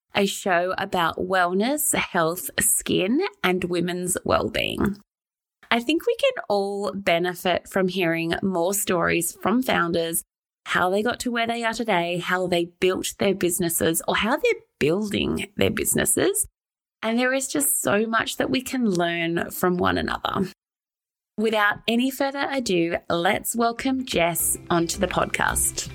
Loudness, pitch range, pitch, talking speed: -23 LUFS, 175-240 Hz, 195 Hz, 150 wpm